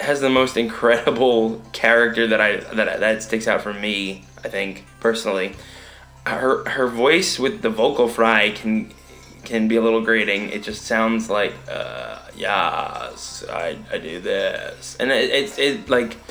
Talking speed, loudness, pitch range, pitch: 160 wpm, -20 LUFS, 105-115 Hz, 110 Hz